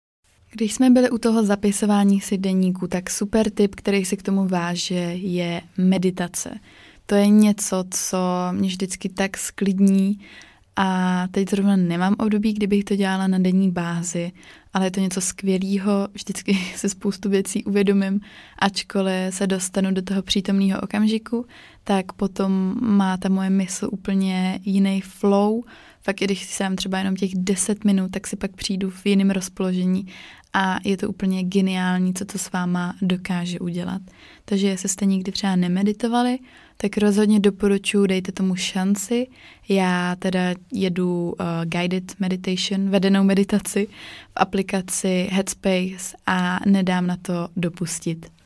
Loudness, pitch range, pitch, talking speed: -22 LUFS, 185-200 Hz, 195 Hz, 145 wpm